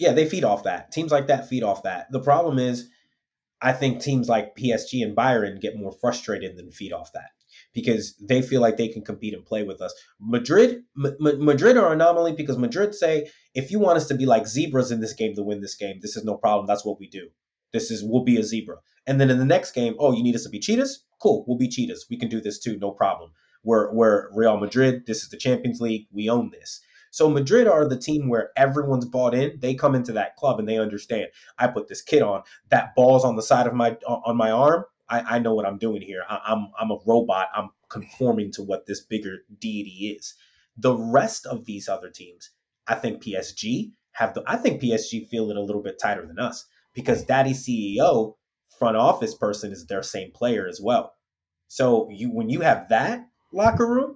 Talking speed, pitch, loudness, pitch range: 230 wpm, 125 Hz, -23 LUFS, 110-145 Hz